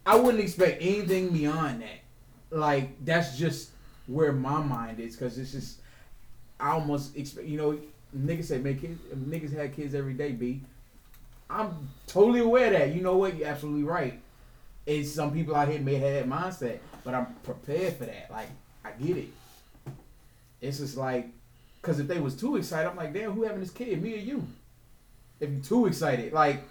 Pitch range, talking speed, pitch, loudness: 130-165 Hz, 190 wpm, 145 Hz, -29 LUFS